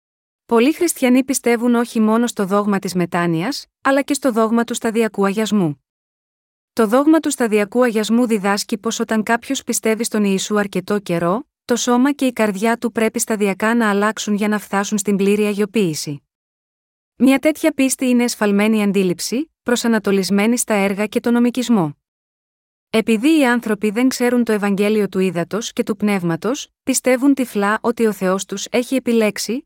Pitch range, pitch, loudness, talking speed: 205-245 Hz, 225 Hz, -17 LUFS, 160 wpm